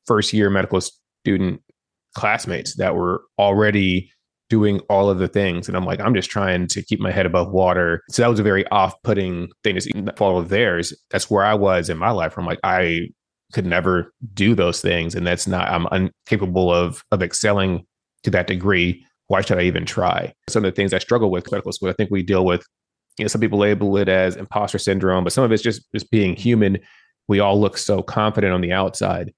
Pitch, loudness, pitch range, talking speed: 95 Hz, -19 LUFS, 90-105 Hz, 220 wpm